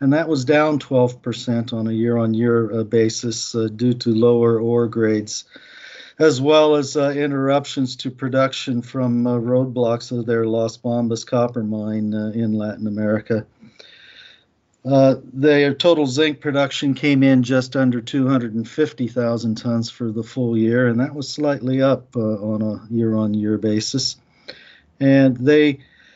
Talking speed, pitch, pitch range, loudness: 140 wpm, 120 Hz, 115-135 Hz, -19 LUFS